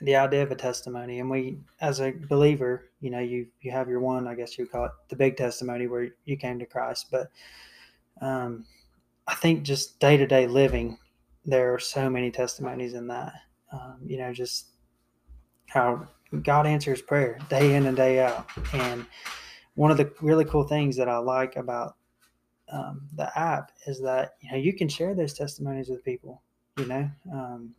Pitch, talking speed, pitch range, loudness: 130 Hz, 190 wpm, 120-140 Hz, -27 LUFS